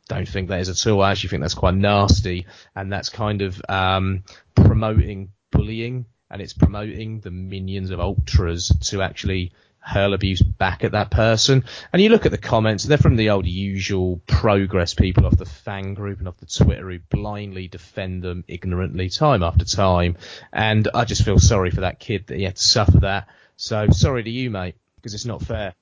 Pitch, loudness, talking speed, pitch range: 100 Hz, -20 LUFS, 200 wpm, 90-110 Hz